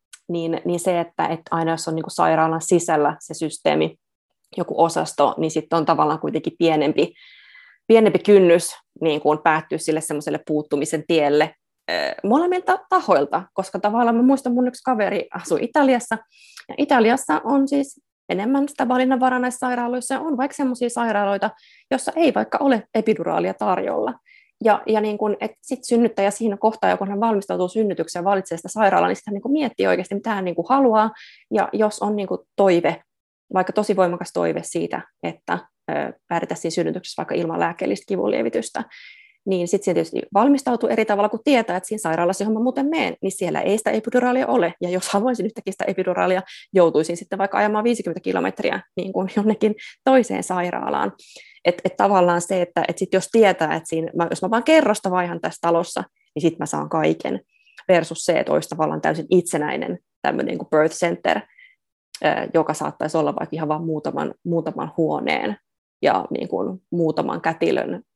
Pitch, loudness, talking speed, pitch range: 200 Hz, -21 LUFS, 170 wpm, 170-245 Hz